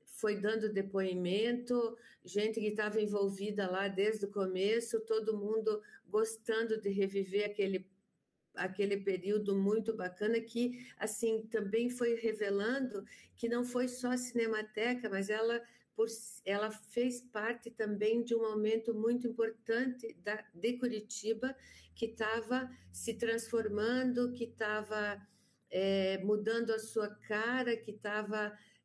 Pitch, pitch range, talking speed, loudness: 220 Hz, 205-230 Hz, 125 wpm, -36 LUFS